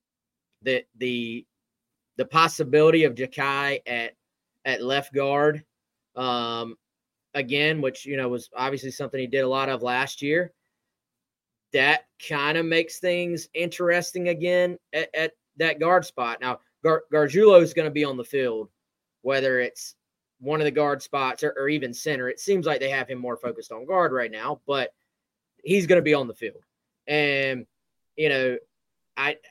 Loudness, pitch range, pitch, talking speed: -24 LUFS, 130-165 Hz, 145 Hz, 165 wpm